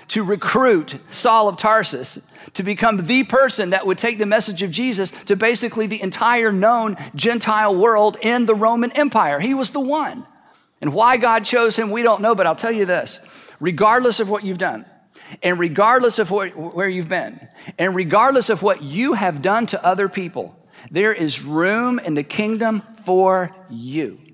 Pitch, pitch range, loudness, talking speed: 215 Hz, 185-230 Hz, -18 LUFS, 180 wpm